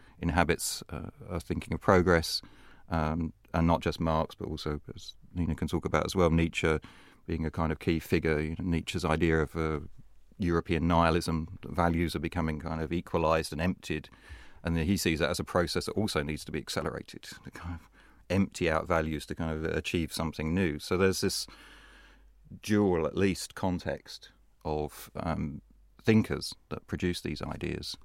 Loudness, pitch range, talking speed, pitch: -31 LUFS, 80-90 Hz, 180 wpm, 85 Hz